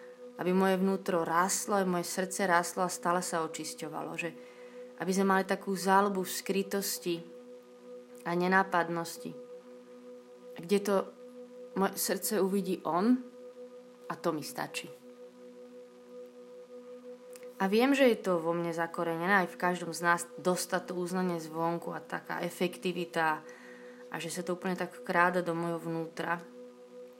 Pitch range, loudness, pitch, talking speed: 165-205 Hz, -31 LUFS, 180 Hz, 130 wpm